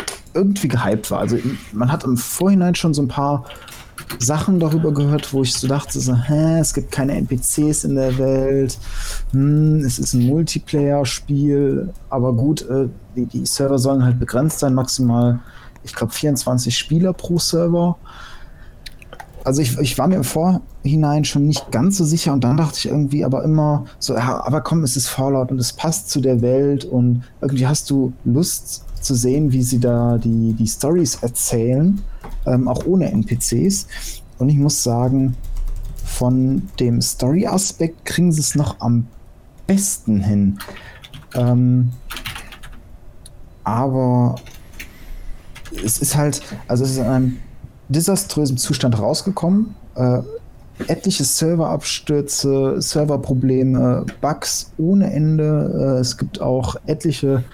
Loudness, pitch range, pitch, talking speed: -18 LUFS, 125-155 Hz, 135 Hz, 145 wpm